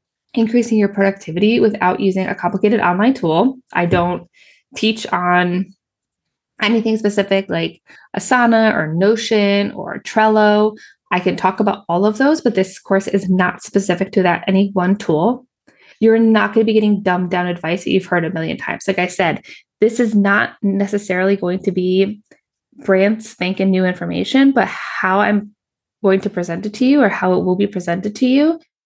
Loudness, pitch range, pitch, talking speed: -16 LUFS, 185-220 Hz, 200 Hz, 175 wpm